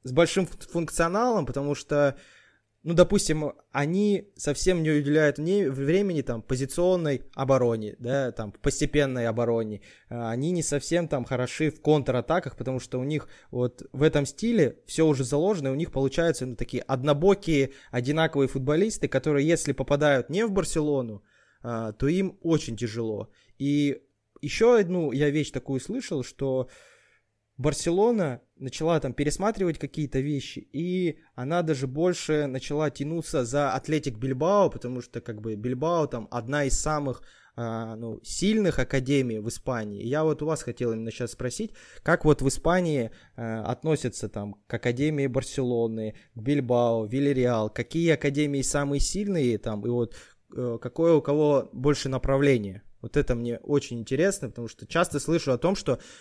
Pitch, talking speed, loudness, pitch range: 140 Hz, 150 wpm, -26 LUFS, 125-160 Hz